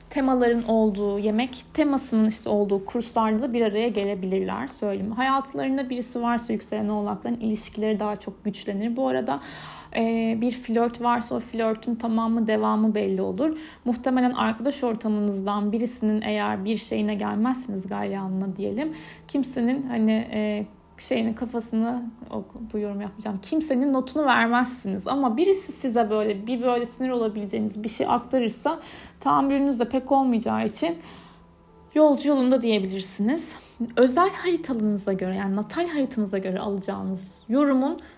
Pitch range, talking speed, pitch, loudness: 210-260 Hz, 130 wpm, 230 Hz, -25 LUFS